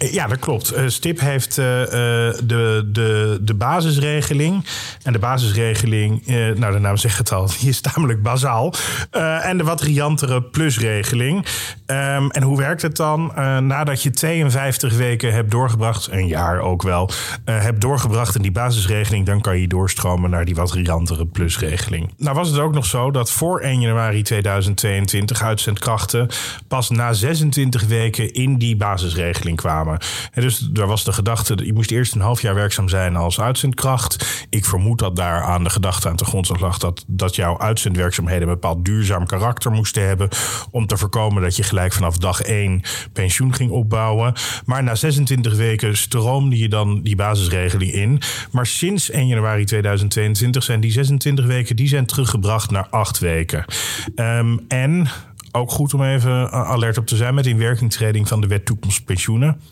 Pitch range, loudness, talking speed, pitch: 100-130 Hz, -18 LUFS, 170 wpm, 115 Hz